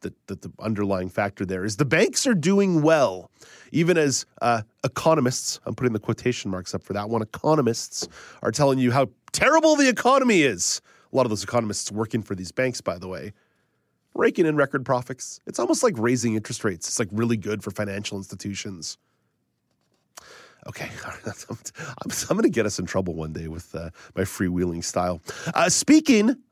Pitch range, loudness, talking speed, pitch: 100-145 Hz, -23 LUFS, 175 wpm, 115 Hz